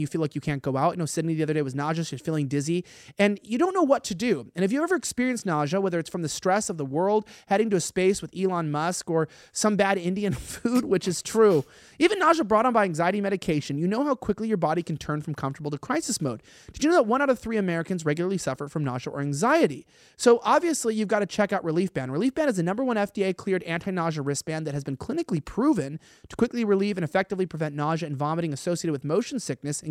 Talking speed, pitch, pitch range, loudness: 255 wpm, 180 Hz, 155-215 Hz, -26 LUFS